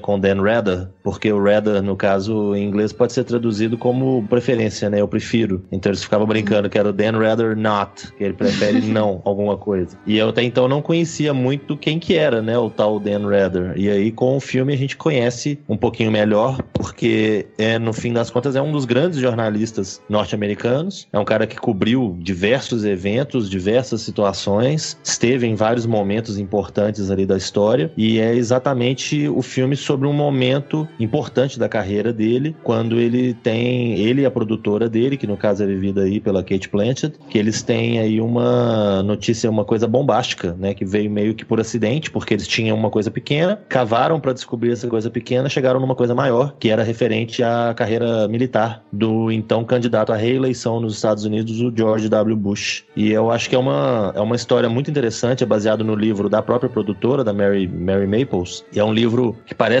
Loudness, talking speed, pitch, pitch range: -19 LUFS, 195 wpm, 115 Hz, 105-125 Hz